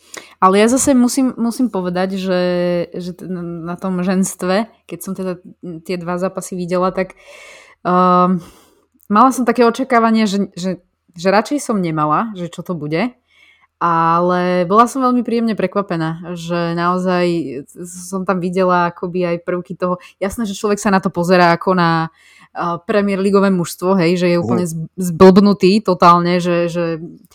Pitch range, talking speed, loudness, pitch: 175-200 Hz, 150 wpm, -16 LUFS, 185 Hz